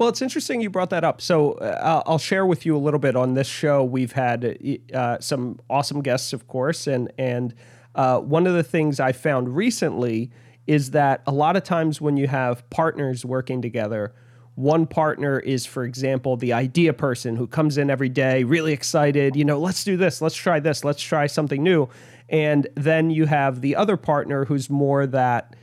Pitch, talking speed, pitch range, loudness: 140 Hz, 200 wpm, 130-160 Hz, -22 LUFS